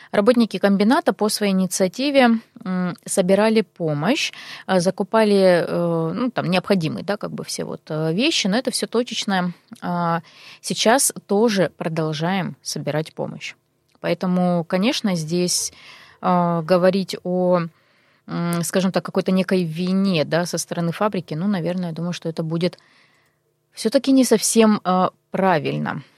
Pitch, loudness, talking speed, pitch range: 185 Hz, -20 LUFS, 115 wpm, 170-210 Hz